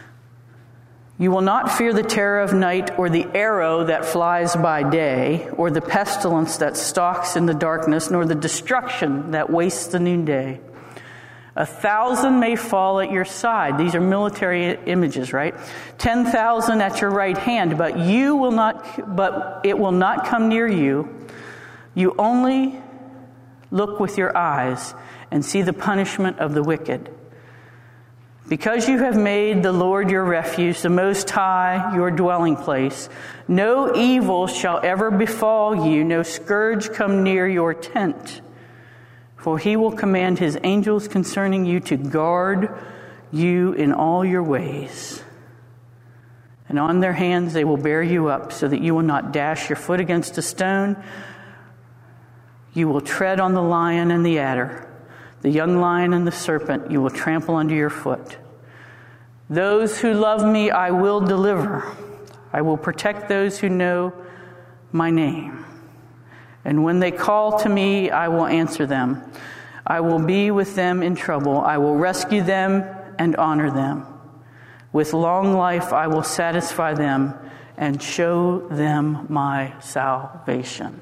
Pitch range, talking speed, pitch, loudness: 145-195 Hz, 150 wpm, 170 Hz, -20 LUFS